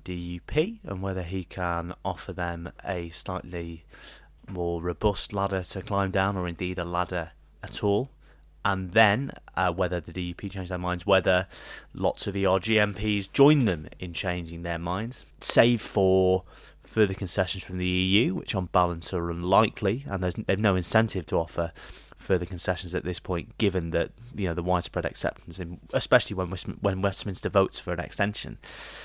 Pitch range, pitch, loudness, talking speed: 90-100 Hz, 95 Hz, -27 LUFS, 165 wpm